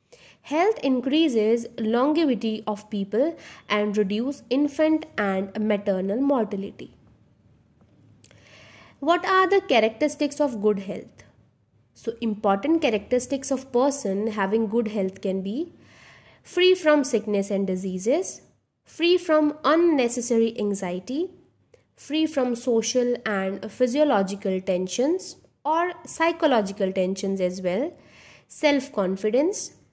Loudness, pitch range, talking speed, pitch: -24 LUFS, 200-295 Hz, 100 wpm, 235 Hz